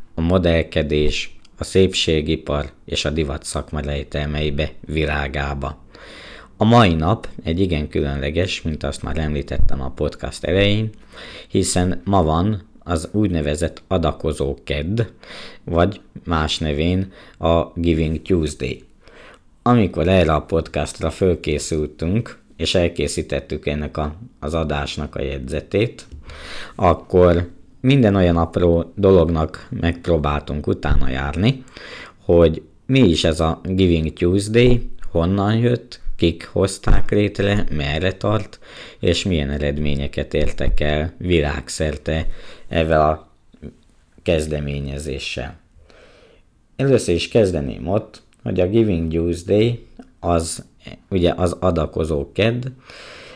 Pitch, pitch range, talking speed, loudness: 80 Hz, 75-95 Hz, 105 wpm, -20 LUFS